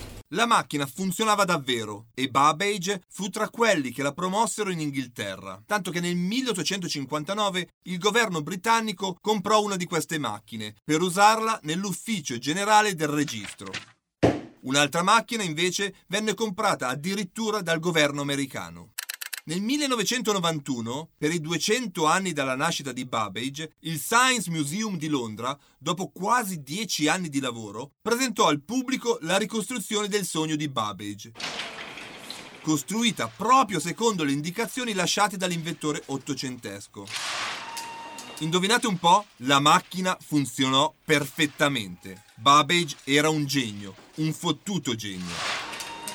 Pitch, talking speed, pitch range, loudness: 170 Hz, 120 wpm, 140-210 Hz, -25 LUFS